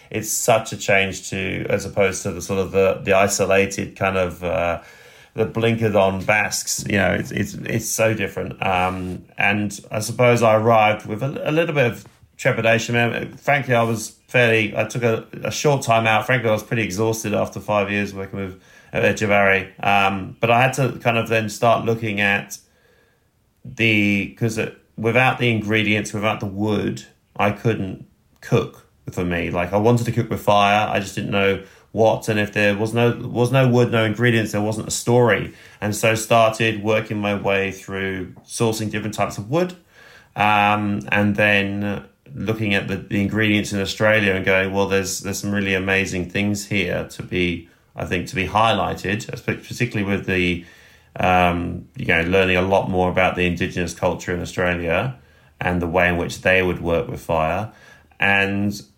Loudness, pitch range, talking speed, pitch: -20 LUFS, 95-110 Hz, 185 wpm, 105 Hz